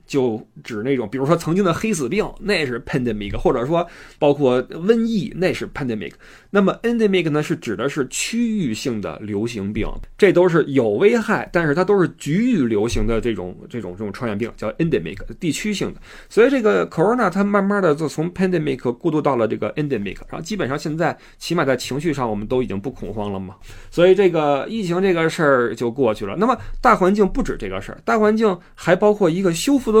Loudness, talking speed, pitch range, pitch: -19 LUFS, 390 characters per minute, 125-200 Hz, 165 Hz